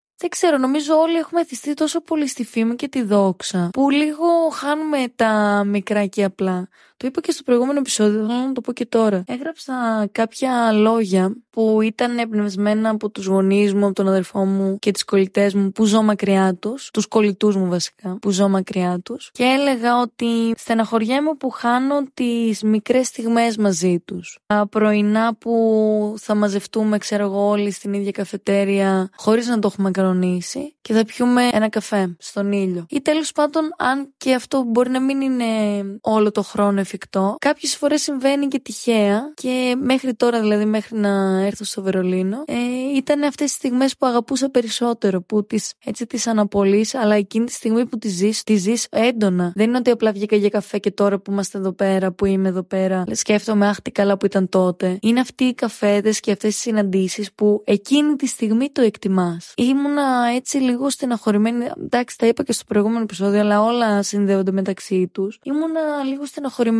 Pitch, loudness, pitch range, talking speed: 220 Hz, -19 LUFS, 200-255 Hz, 180 wpm